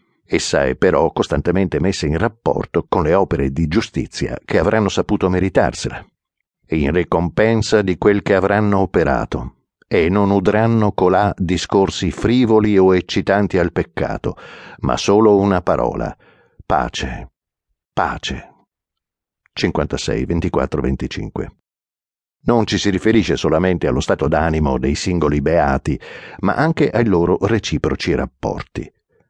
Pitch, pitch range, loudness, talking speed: 95 Hz, 85-105 Hz, -17 LUFS, 120 wpm